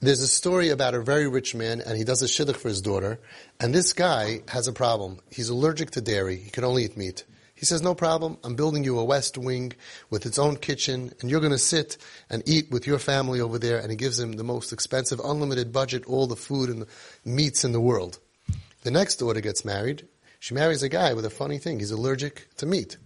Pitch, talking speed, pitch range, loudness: 125 Hz, 240 wpm, 115-145 Hz, -25 LUFS